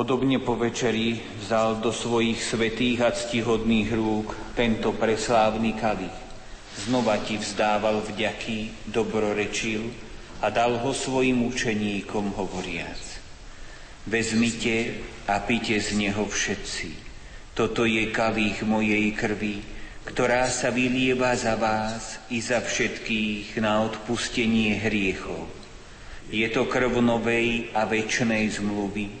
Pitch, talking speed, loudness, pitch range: 110 Hz, 110 wpm, -25 LUFS, 105-115 Hz